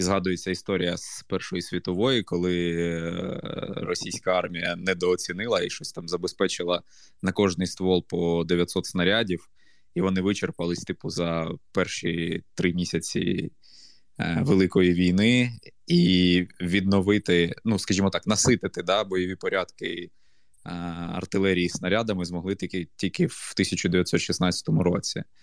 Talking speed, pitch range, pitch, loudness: 110 wpm, 85-95 Hz, 90 Hz, -25 LUFS